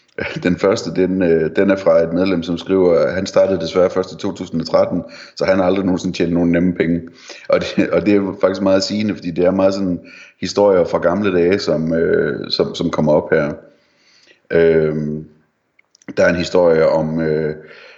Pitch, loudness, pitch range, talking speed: 90 Hz, -16 LUFS, 80-95 Hz, 180 wpm